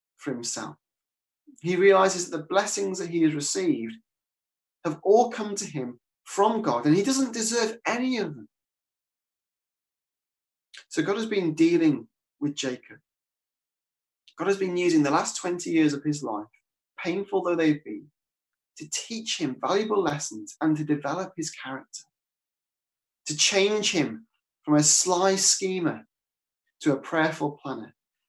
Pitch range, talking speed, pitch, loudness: 145-205 Hz, 145 wpm, 180 Hz, -25 LUFS